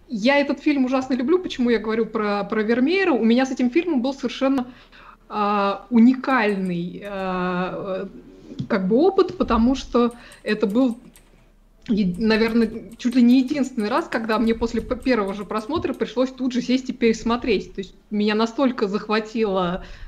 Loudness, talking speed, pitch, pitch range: -21 LUFS, 150 wpm, 235 Hz, 215-260 Hz